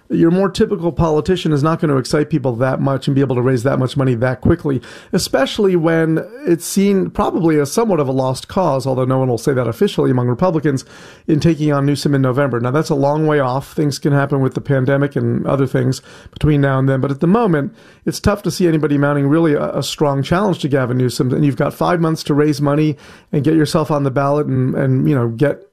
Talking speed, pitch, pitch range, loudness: 245 wpm, 145 Hz, 135-160 Hz, -16 LUFS